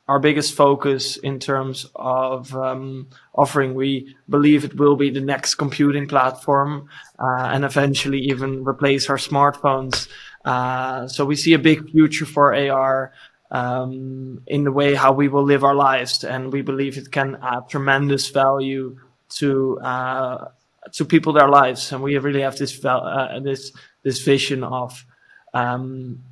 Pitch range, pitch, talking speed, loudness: 130-140 Hz, 135 Hz, 155 wpm, -19 LUFS